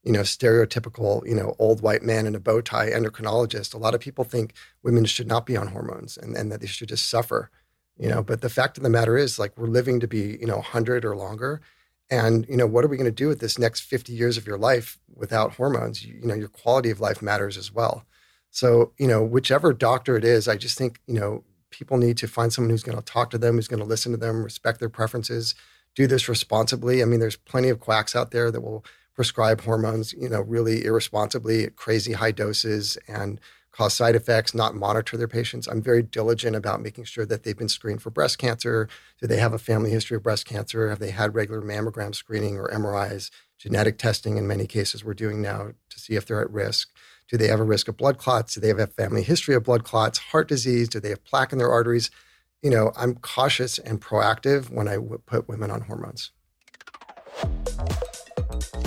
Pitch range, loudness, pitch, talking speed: 110-120 Hz, -24 LUFS, 115 Hz, 230 wpm